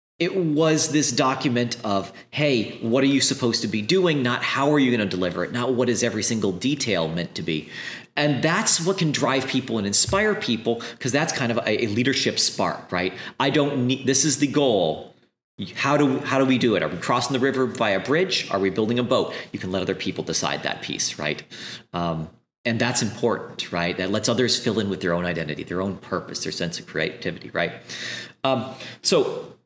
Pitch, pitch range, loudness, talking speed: 125 Hz, 110-140 Hz, -23 LUFS, 220 wpm